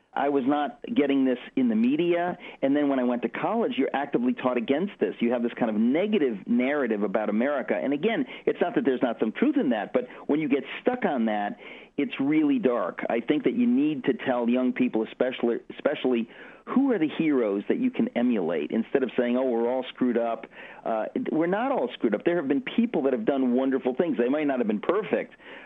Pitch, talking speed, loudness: 140 Hz, 230 wpm, -26 LUFS